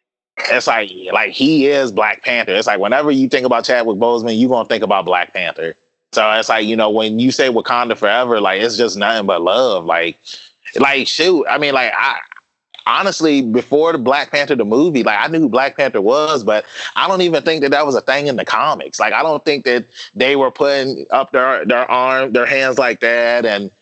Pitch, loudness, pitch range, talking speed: 130 Hz, -14 LUFS, 120-145 Hz, 225 wpm